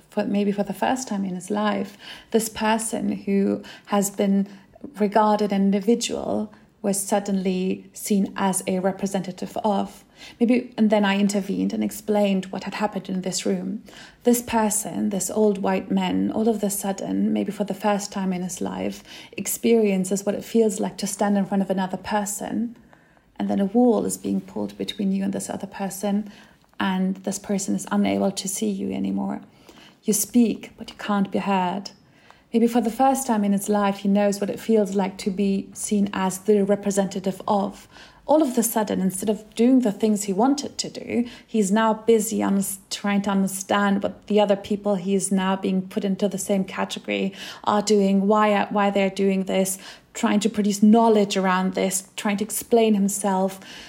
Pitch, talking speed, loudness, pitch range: 200 Hz, 185 wpm, -23 LUFS, 195-215 Hz